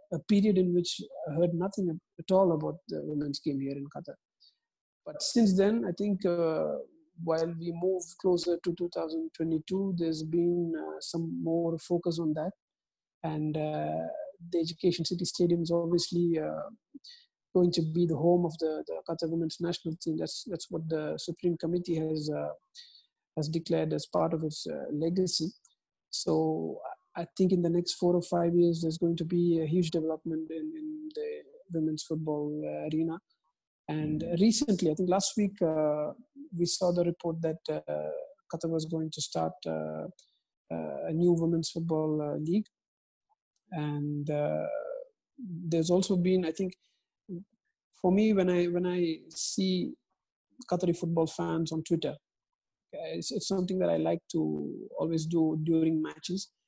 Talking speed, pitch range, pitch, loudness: 160 wpm, 160-185 Hz, 170 Hz, -31 LUFS